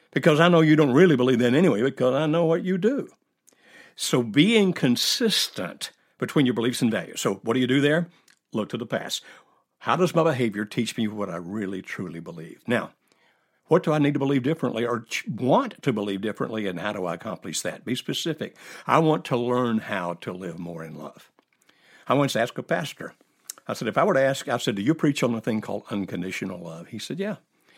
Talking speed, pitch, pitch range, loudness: 220 wpm, 125 Hz, 105-160 Hz, -24 LUFS